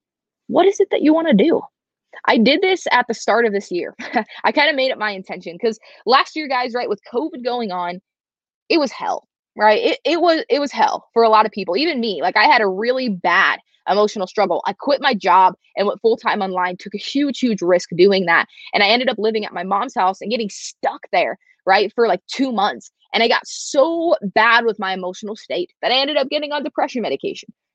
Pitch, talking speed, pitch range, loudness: 230 Hz, 235 wpm, 200-280 Hz, -18 LUFS